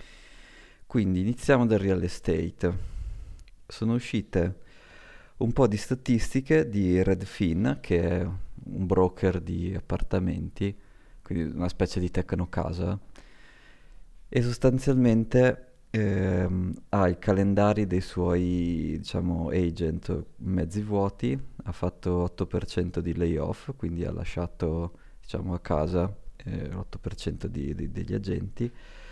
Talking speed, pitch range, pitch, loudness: 105 wpm, 85-105 Hz, 95 Hz, -28 LUFS